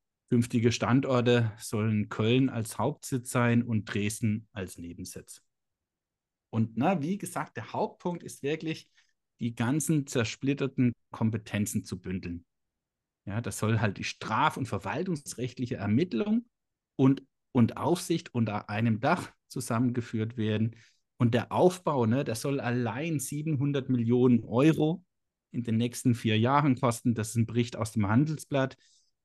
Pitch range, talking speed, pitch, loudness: 110-140 Hz, 135 wpm, 120 Hz, -29 LUFS